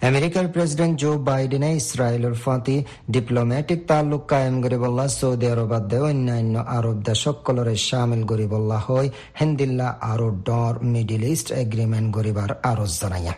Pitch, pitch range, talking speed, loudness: 125 Hz, 115-140 Hz, 130 wpm, -22 LUFS